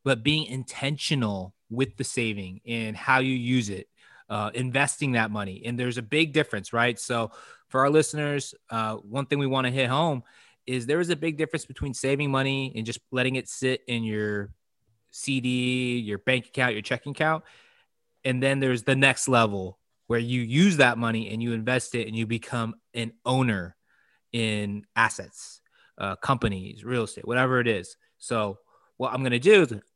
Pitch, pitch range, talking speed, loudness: 125 Hz, 115-135 Hz, 185 wpm, -26 LUFS